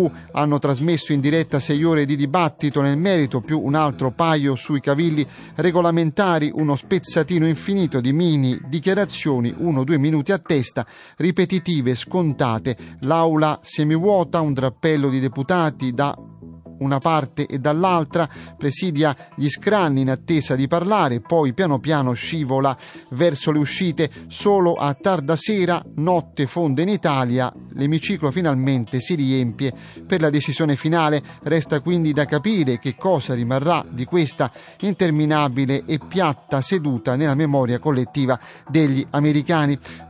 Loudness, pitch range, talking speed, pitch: -20 LUFS, 135-170 Hz, 135 wpm, 150 Hz